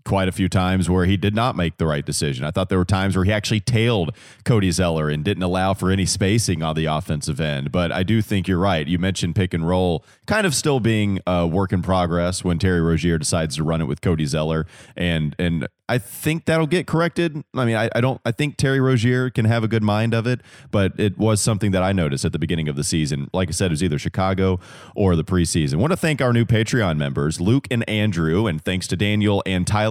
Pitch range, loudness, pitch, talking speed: 85-115 Hz, -20 LUFS, 95 Hz, 250 wpm